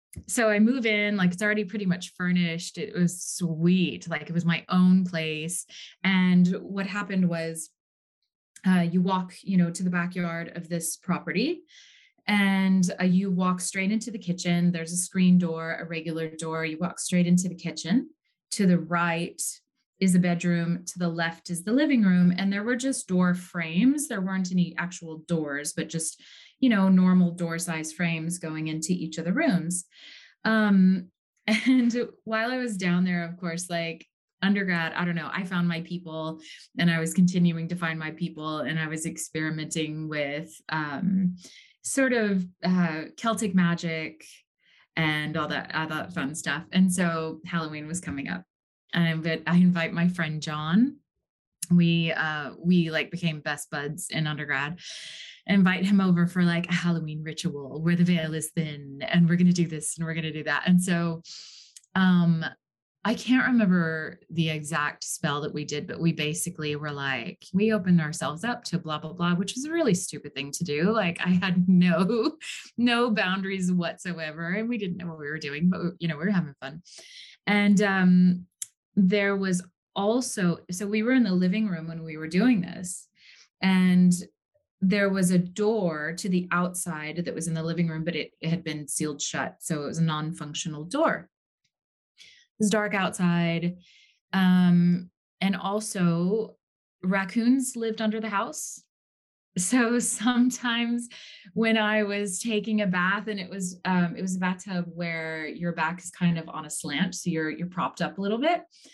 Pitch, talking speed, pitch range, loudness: 180 Hz, 180 wpm, 165-200 Hz, -26 LUFS